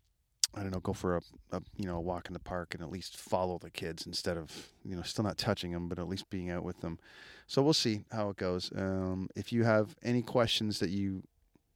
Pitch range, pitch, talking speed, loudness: 90-105 Hz, 95 Hz, 250 wpm, -35 LUFS